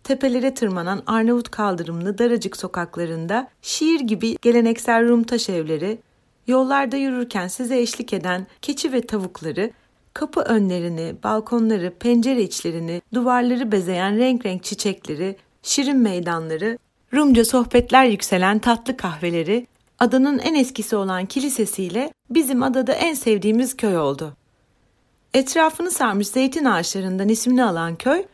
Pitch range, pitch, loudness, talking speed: 190-255 Hz, 230 Hz, -20 LUFS, 115 wpm